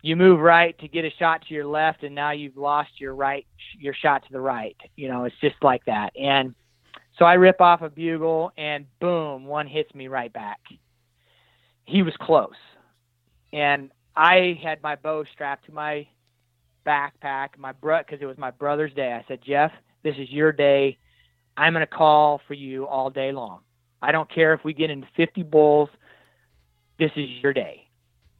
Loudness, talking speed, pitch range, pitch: -22 LUFS, 190 wpm, 130-155 Hz, 145 Hz